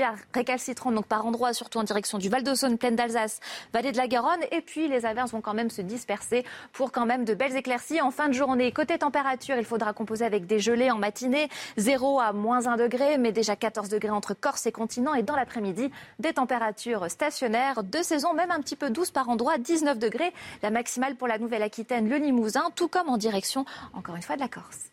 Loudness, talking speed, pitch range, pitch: -27 LUFS, 220 wpm, 225-275 Hz, 245 Hz